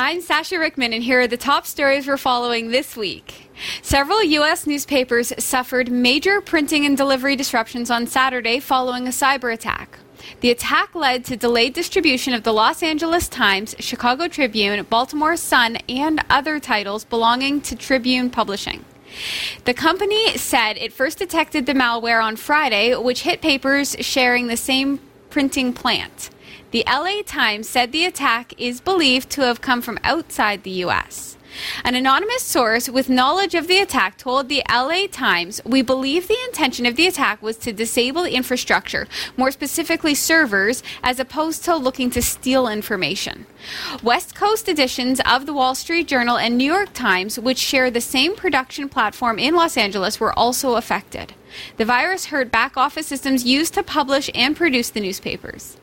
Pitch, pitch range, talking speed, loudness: 260 Hz, 240-305 Hz, 165 wpm, -18 LUFS